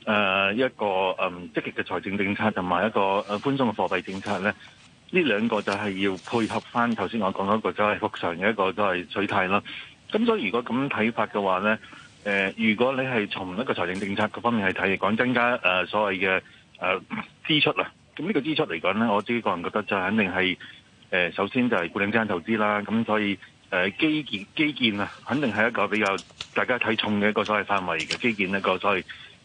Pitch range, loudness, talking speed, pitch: 95-115 Hz, -25 LUFS, 325 characters per minute, 105 Hz